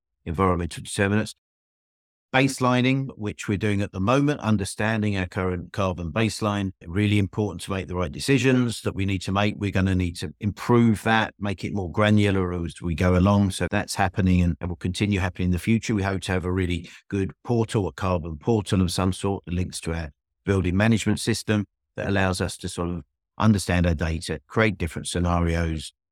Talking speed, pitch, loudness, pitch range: 195 wpm, 95 Hz, -24 LUFS, 90-105 Hz